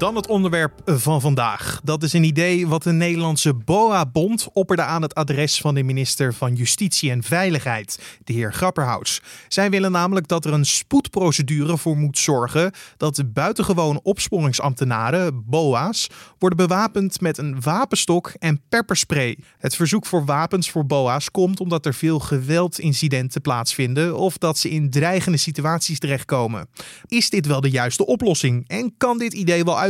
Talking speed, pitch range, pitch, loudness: 160 wpm, 140-180 Hz, 160 Hz, -20 LUFS